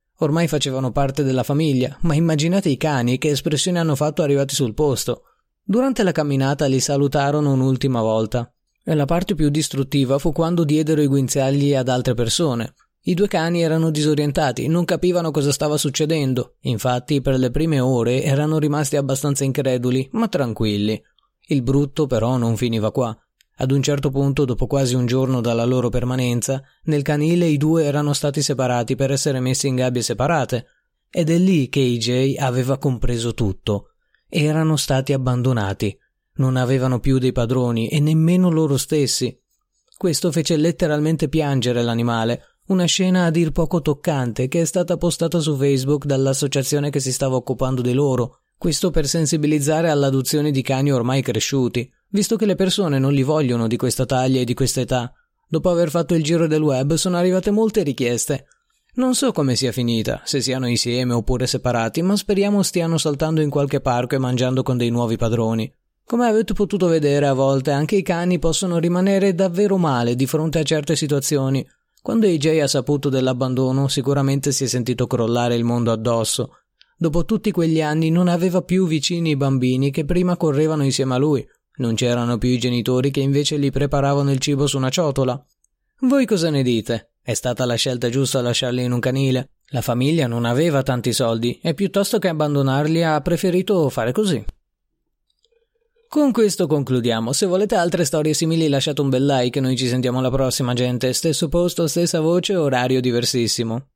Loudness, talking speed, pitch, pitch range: -19 LUFS, 175 wpm, 140 Hz, 125-165 Hz